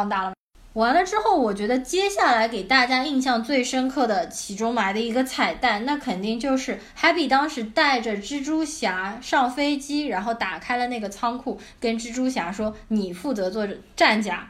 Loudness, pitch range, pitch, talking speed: -23 LUFS, 220-275 Hz, 245 Hz, 275 characters per minute